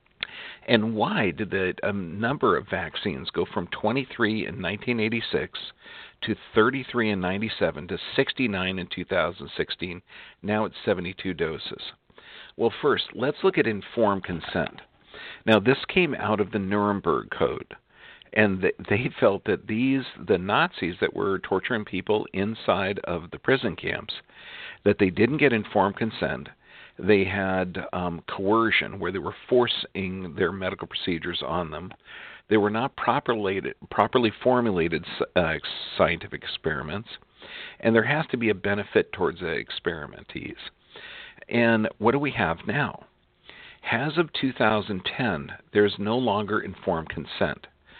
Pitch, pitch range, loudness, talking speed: 110 Hz, 100-115 Hz, -26 LUFS, 135 wpm